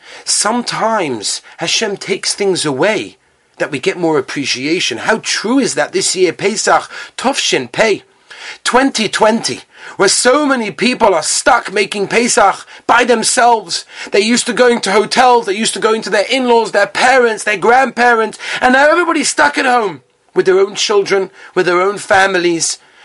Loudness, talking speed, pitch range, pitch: -13 LUFS, 165 wpm, 200-255 Hz, 230 Hz